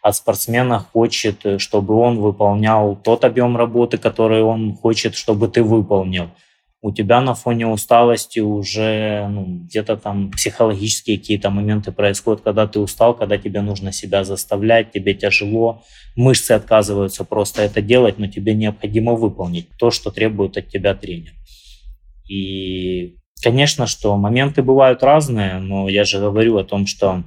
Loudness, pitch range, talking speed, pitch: -17 LUFS, 100-115 Hz, 145 wpm, 105 Hz